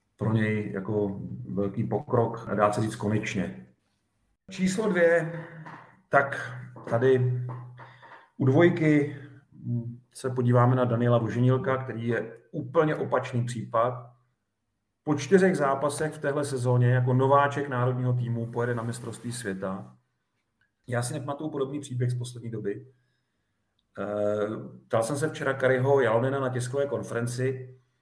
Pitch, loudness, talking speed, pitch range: 125 Hz, -27 LUFS, 120 wpm, 110-140 Hz